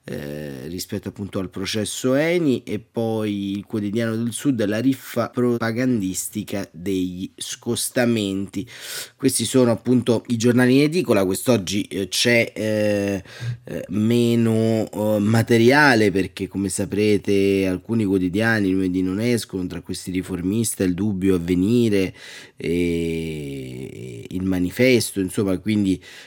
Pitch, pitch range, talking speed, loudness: 105 Hz, 95-115 Hz, 115 wpm, -21 LUFS